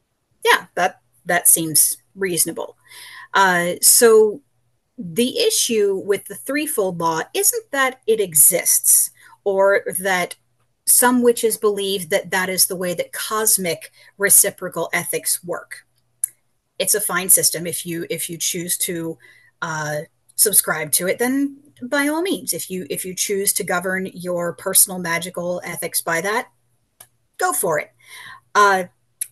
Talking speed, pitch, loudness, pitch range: 135 wpm, 190 Hz, -17 LUFS, 170-220 Hz